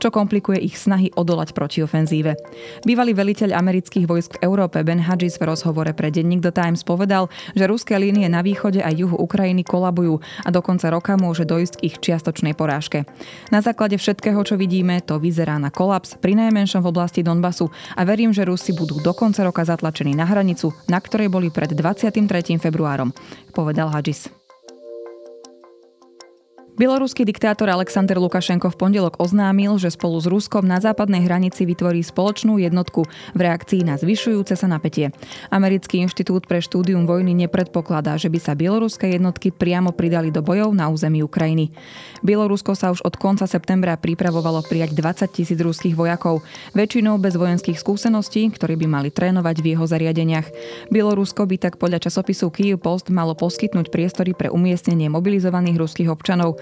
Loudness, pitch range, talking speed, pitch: -19 LUFS, 165-195 Hz, 160 wpm, 180 Hz